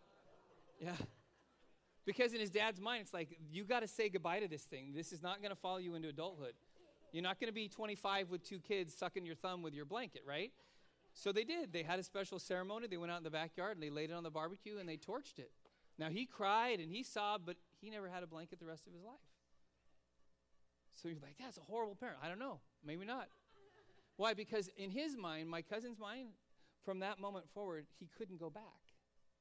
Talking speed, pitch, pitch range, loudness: 225 wpm, 185 Hz, 160-215 Hz, -45 LUFS